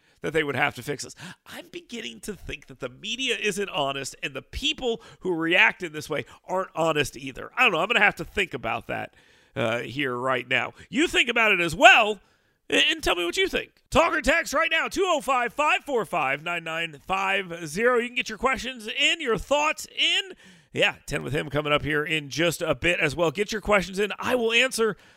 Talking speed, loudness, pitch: 215 wpm, -23 LUFS, 200 Hz